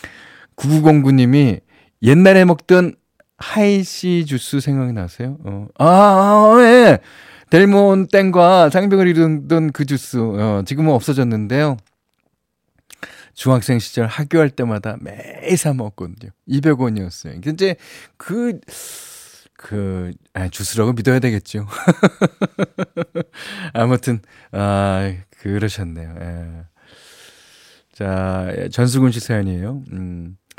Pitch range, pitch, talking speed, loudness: 105-175 Hz, 130 Hz, 200 characters per minute, -15 LUFS